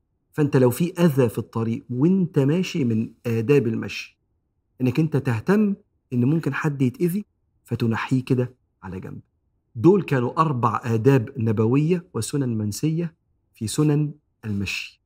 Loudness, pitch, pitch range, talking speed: -22 LUFS, 130 Hz, 115-155 Hz, 130 wpm